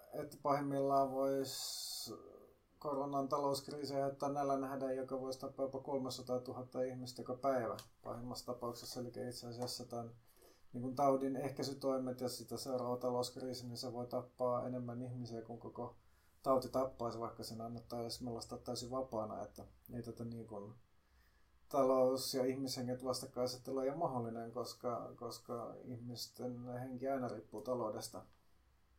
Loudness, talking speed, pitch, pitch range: -41 LUFS, 135 wpm, 125 Hz, 120-135 Hz